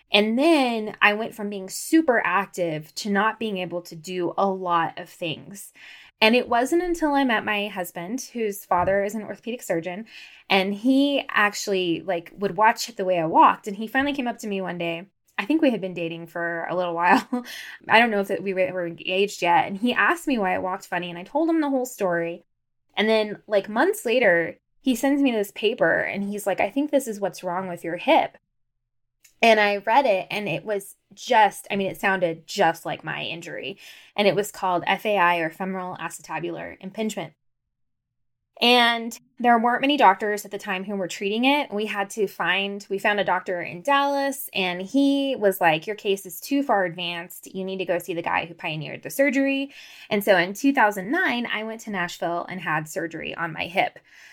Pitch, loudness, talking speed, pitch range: 200 Hz, -23 LUFS, 210 wpm, 175-235 Hz